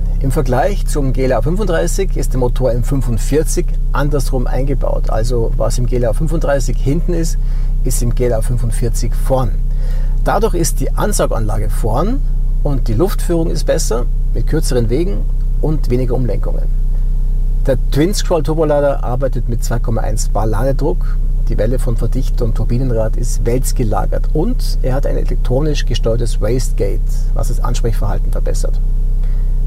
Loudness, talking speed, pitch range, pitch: -18 LUFS, 130 wpm, 120-140 Hz, 130 Hz